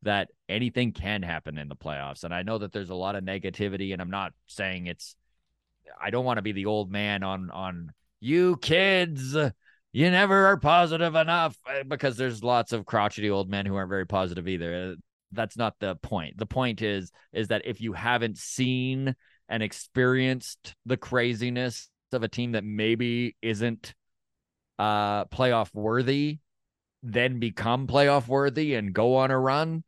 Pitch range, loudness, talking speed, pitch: 100-130 Hz, -27 LUFS, 170 wpm, 115 Hz